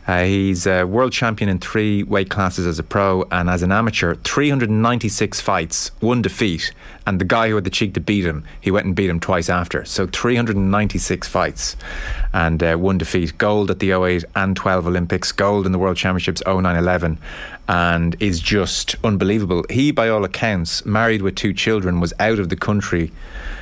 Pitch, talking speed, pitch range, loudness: 95 Hz, 190 wpm, 90-105 Hz, -19 LUFS